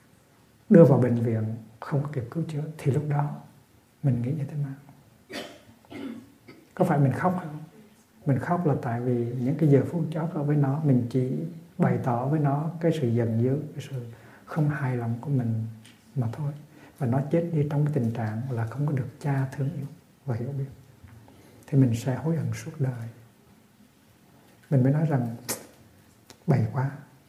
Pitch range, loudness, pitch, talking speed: 120-150 Hz, -26 LUFS, 135 Hz, 185 wpm